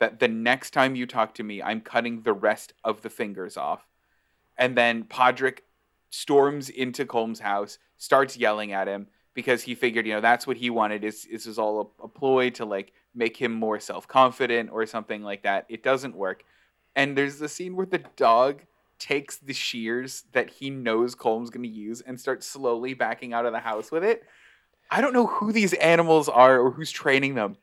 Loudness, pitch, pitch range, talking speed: -25 LUFS, 120 Hz, 115-135 Hz, 200 wpm